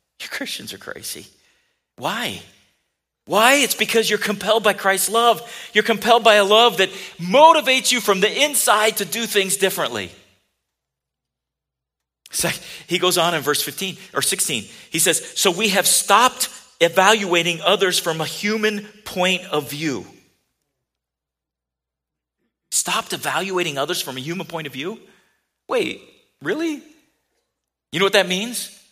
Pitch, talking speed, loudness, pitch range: 195 Hz, 140 wpm, -18 LUFS, 165-220 Hz